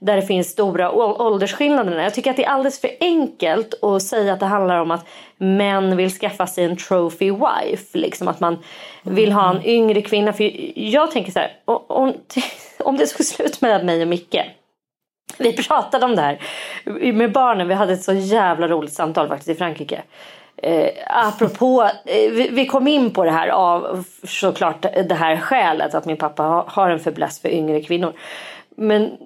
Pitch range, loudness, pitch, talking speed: 175-240 Hz, -18 LUFS, 195 Hz, 180 wpm